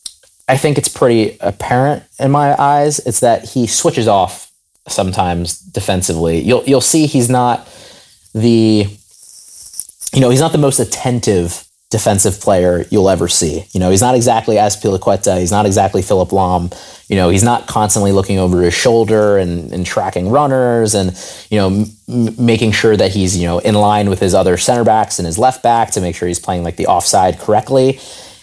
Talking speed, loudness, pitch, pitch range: 185 wpm, -13 LUFS, 105 Hz, 90-125 Hz